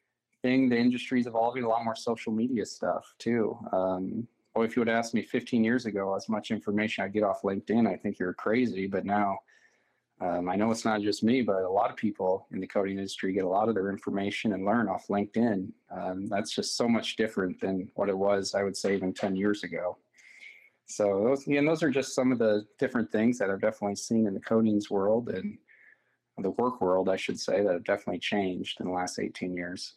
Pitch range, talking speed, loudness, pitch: 95-115 Hz, 225 wpm, -29 LUFS, 105 Hz